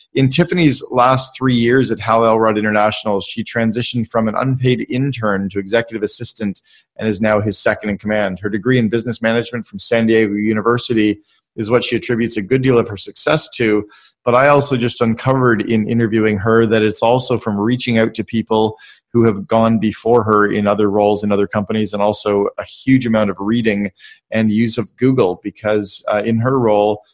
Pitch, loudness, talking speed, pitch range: 115 Hz, -16 LUFS, 195 wpm, 105-120 Hz